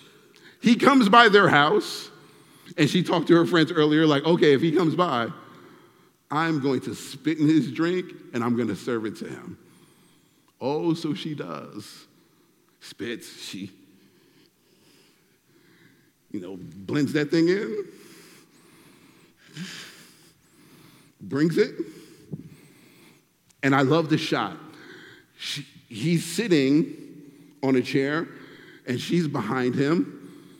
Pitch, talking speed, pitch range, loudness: 155 Hz, 120 wpm, 140-170 Hz, -23 LUFS